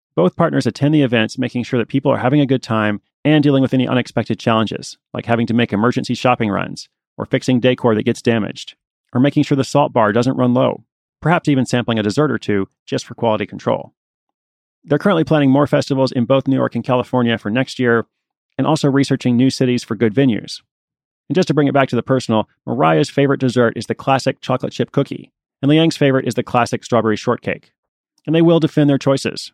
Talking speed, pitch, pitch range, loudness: 215 wpm, 130 Hz, 115-140 Hz, -17 LUFS